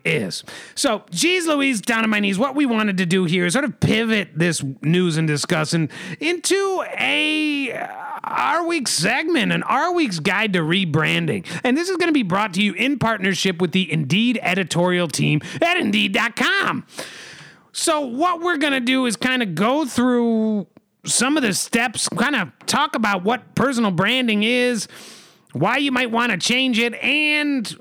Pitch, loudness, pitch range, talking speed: 230 Hz, -19 LUFS, 185-280 Hz, 180 wpm